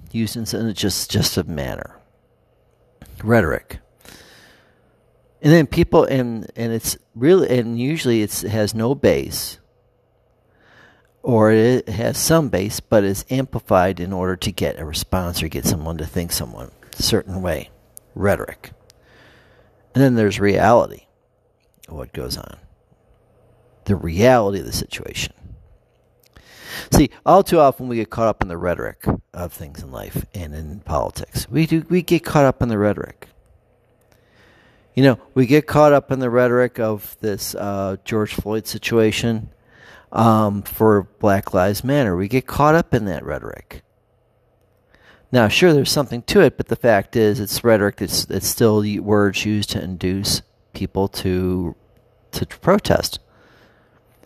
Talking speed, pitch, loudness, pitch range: 150 wpm, 110 Hz, -19 LUFS, 95-125 Hz